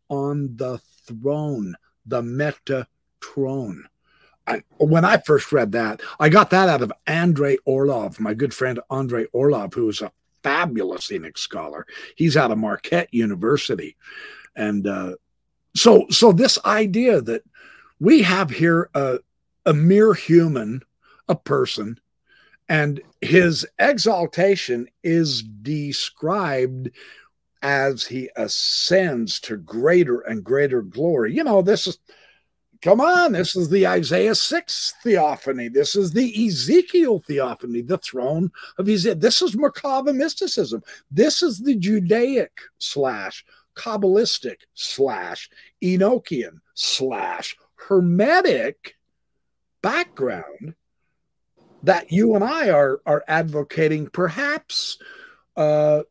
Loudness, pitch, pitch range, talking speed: -20 LUFS, 170 Hz, 140-215 Hz, 115 wpm